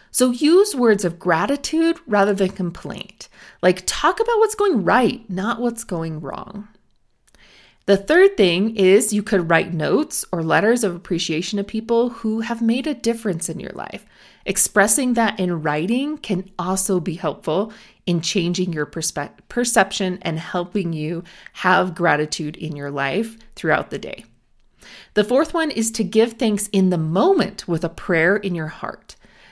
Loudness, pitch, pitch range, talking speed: -19 LUFS, 195 Hz, 175-230 Hz, 165 wpm